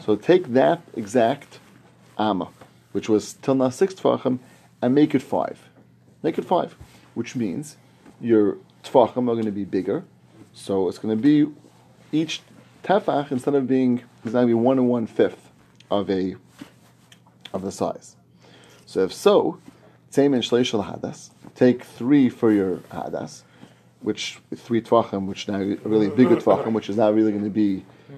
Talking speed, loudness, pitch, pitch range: 155 wpm, -22 LUFS, 115 Hz, 100-130 Hz